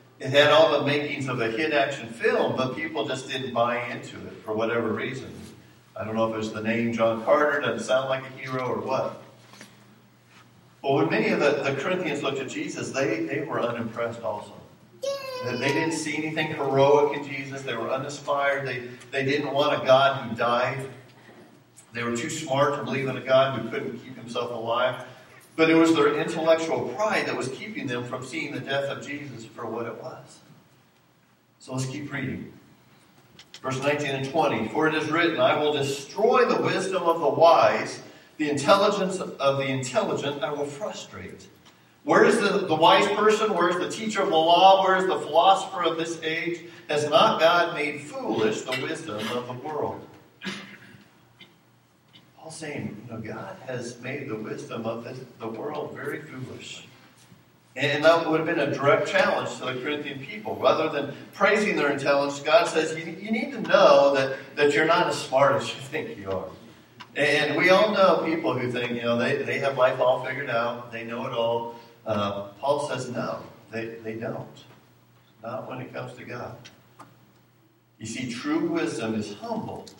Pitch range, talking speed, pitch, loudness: 120-160 Hz, 190 wpm, 135 Hz, -24 LUFS